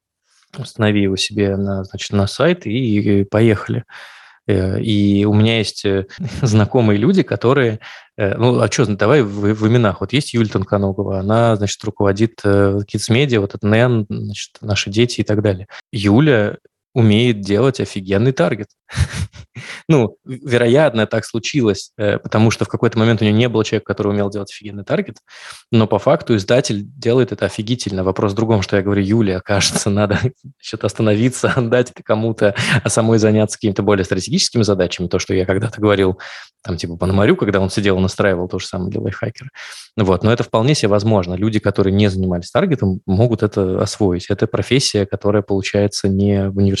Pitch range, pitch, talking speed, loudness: 100-115 Hz, 105 Hz, 170 wpm, -16 LUFS